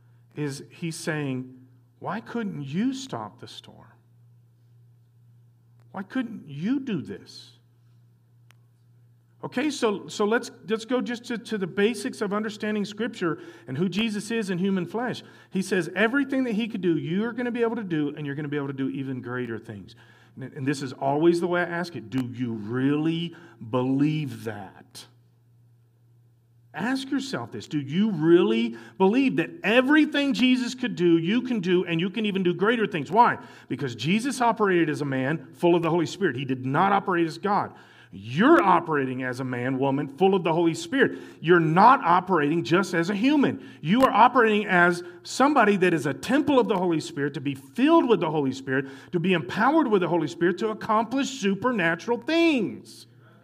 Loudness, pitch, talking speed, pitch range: -24 LUFS, 170 Hz, 180 wpm, 130-215 Hz